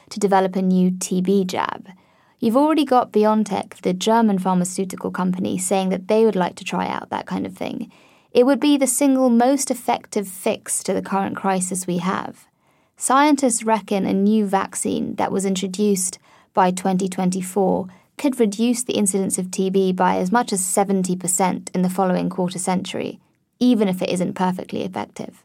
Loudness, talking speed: -20 LUFS, 170 wpm